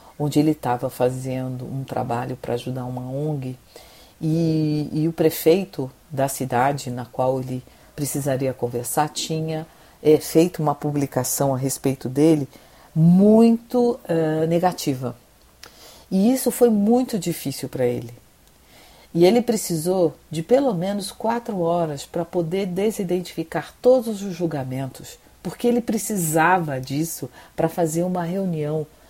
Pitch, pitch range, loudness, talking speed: 160 Hz, 135-180 Hz, -22 LUFS, 125 wpm